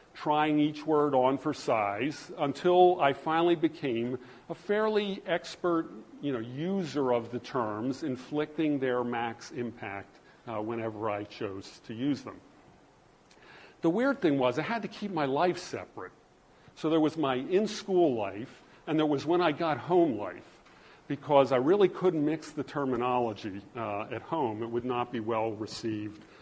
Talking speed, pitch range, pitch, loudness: 165 wpm, 120-165 Hz, 145 Hz, -30 LUFS